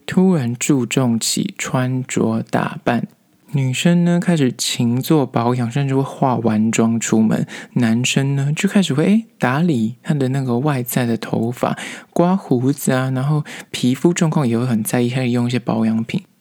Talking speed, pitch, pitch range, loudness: 250 characters per minute, 130 Hz, 120-165 Hz, -18 LUFS